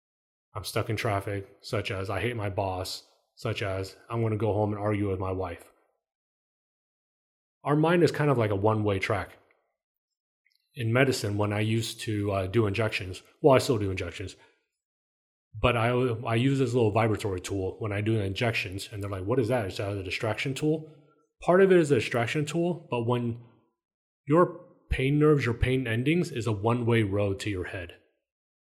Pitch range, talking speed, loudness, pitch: 100-130 Hz, 190 wpm, -27 LUFS, 110 Hz